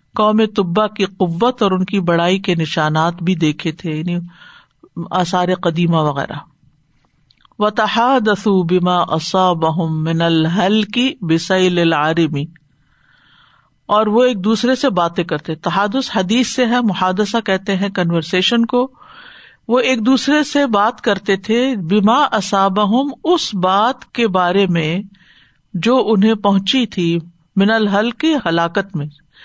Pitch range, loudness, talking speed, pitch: 170-225 Hz, -16 LUFS, 130 wpm, 195 Hz